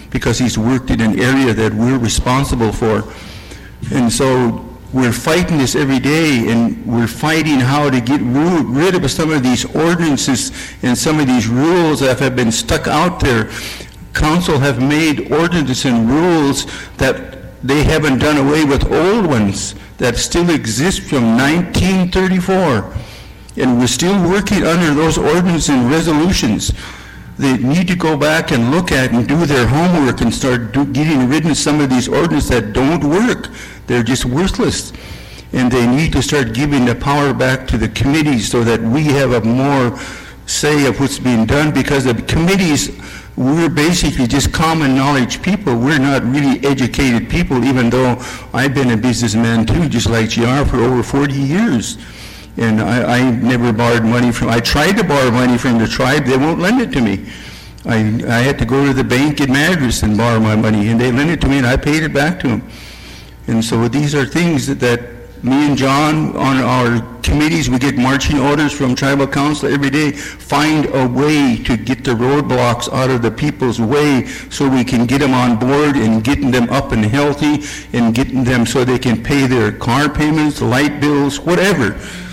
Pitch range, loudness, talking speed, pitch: 120-150 Hz, -14 LUFS, 185 wpm, 130 Hz